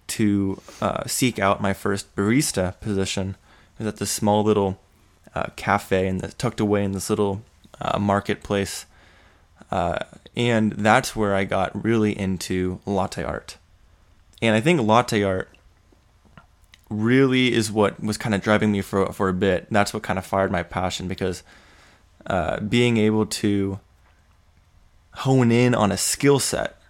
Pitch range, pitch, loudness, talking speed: 95-105 Hz, 100 Hz, -22 LUFS, 155 wpm